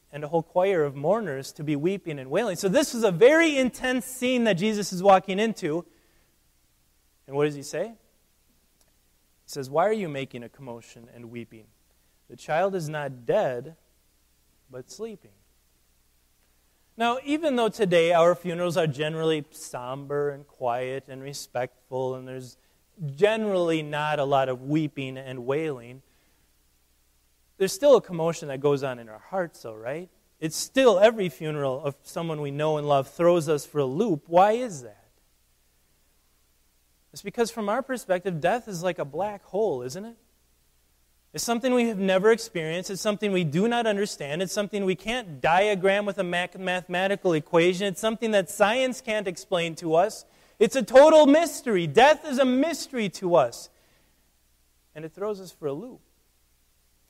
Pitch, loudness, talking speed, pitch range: 160 Hz, -25 LUFS, 165 wpm, 120-200 Hz